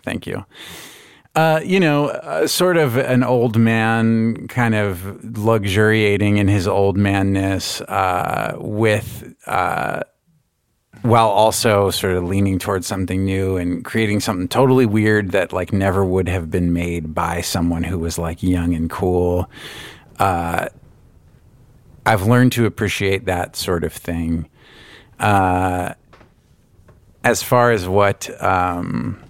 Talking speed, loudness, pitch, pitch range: 130 wpm, -18 LUFS, 100 Hz, 90-115 Hz